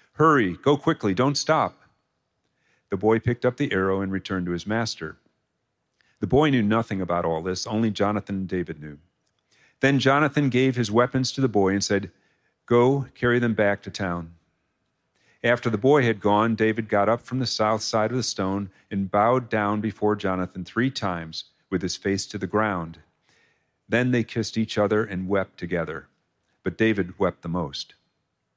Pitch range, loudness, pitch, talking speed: 95-120 Hz, -24 LUFS, 105 Hz, 180 wpm